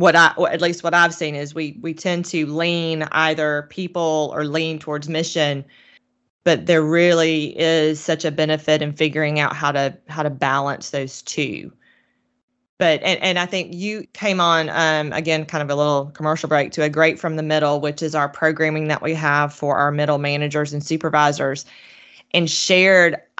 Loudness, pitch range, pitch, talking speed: -19 LUFS, 150-165 Hz, 155 Hz, 190 wpm